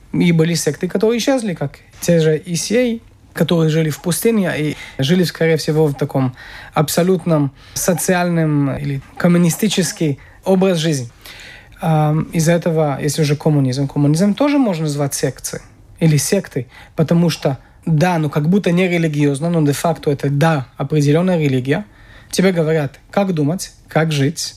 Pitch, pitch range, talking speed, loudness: 160 Hz, 145-175 Hz, 140 wpm, -17 LUFS